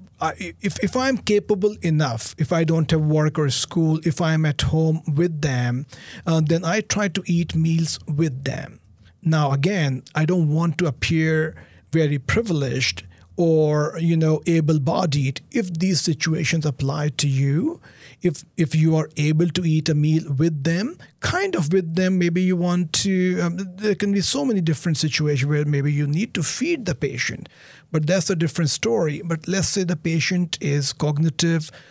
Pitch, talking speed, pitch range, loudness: 160 Hz, 180 wpm, 150-180 Hz, -21 LUFS